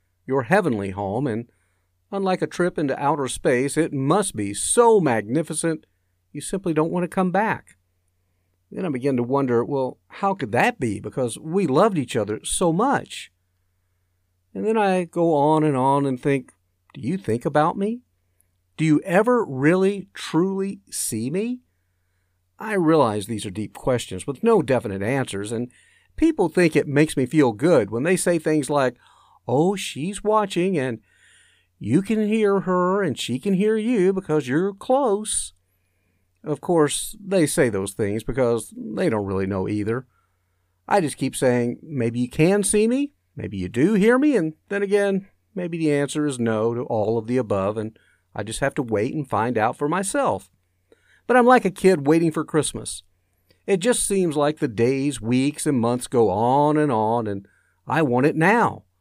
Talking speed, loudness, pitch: 180 wpm, -22 LUFS, 140 Hz